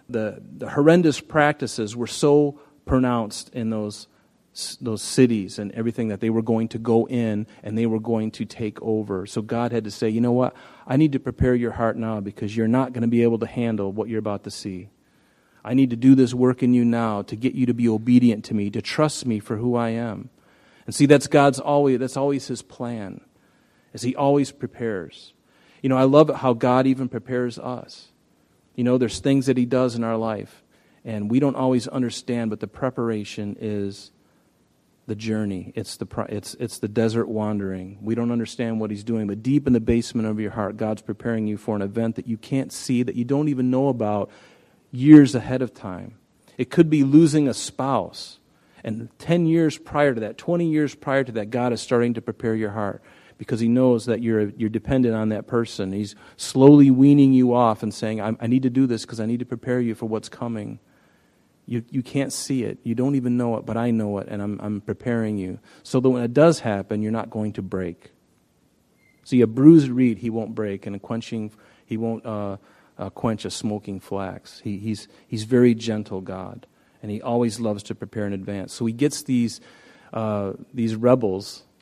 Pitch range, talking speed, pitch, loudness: 110-125 Hz, 220 wpm, 115 Hz, -22 LUFS